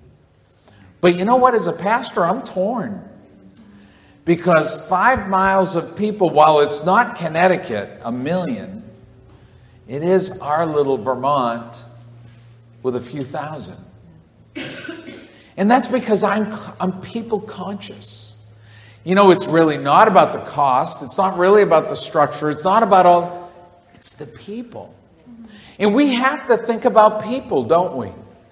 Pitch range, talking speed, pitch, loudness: 135-210 Hz, 140 wpm, 180 Hz, -17 LUFS